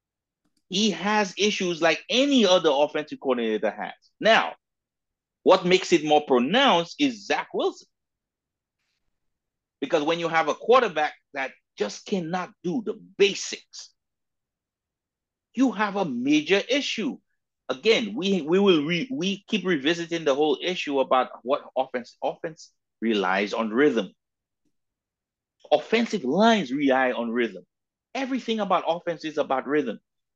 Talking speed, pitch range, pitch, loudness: 125 wpm, 150-225 Hz, 185 Hz, -24 LUFS